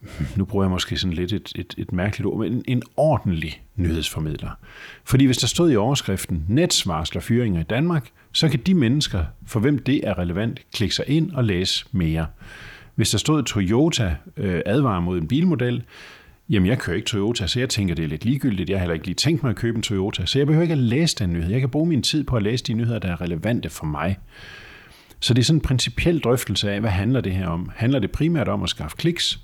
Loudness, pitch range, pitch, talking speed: -22 LUFS, 95-130 Hz, 110 Hz, 235 wpm